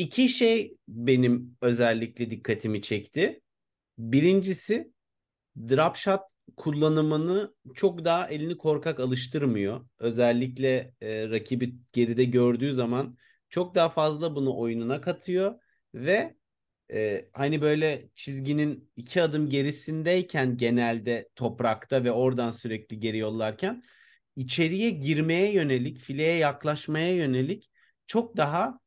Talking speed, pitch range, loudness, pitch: 105 wpm, 120-170 Hz, -27 LUFS, 140 Hz